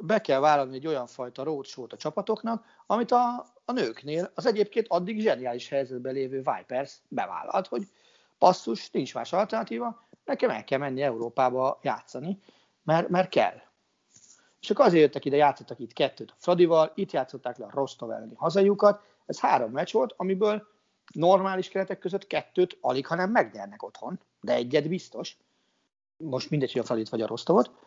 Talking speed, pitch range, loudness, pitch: 165 wpm, 135-205 Hz, -27 LUFS, 175 Hz